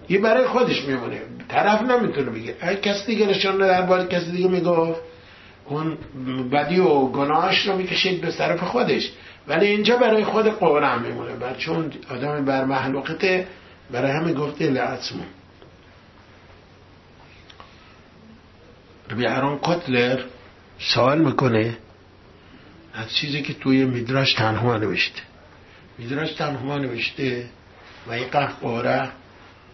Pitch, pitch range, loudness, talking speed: 135 Hz, 110-175 Hz, -21 LUFS, 115 wpm